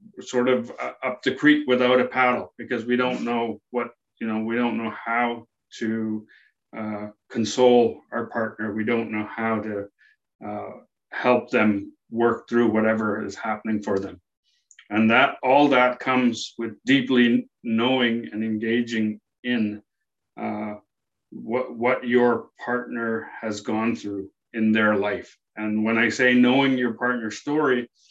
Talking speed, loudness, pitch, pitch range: 145 wpm, -23 LUFS, 115 Hz, 110-125 Hz